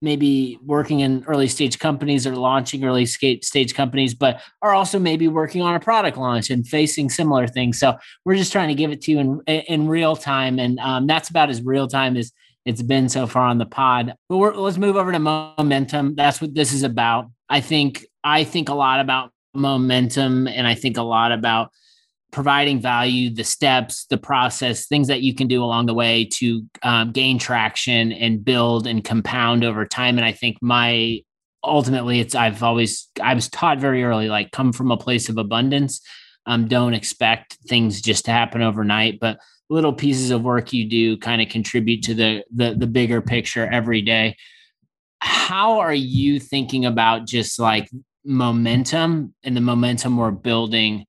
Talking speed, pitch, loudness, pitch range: 190 wpm, 125 Hz, -19 LUFS, 115-140 Hz